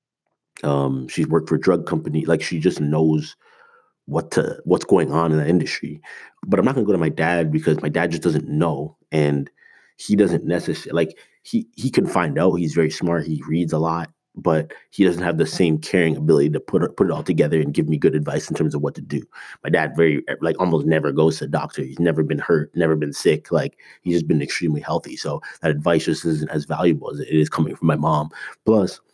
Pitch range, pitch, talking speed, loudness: 75-80 Hz, 80 Hz, 235 wpm, -21 LUFS